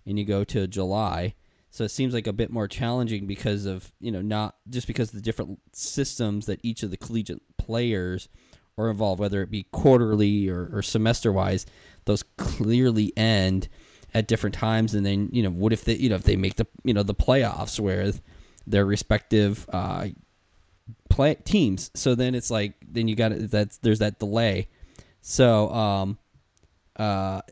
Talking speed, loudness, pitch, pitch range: 185 wpm, -25 LUFS, 105 Hz, 95-115 Hz